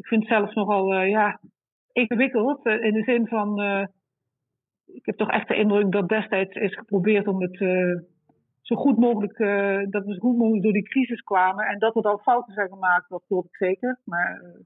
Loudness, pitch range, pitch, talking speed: -23 LUFS, 185-220 Hz, 205 Hz, 220 wpm